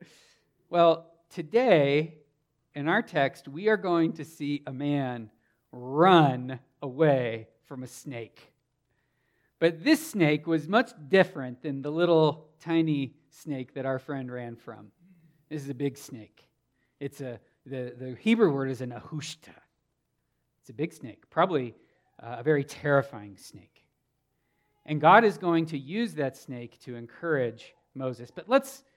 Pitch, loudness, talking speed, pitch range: 145 Hz, -27 LUFS, 145 wpm, 130-165 Hz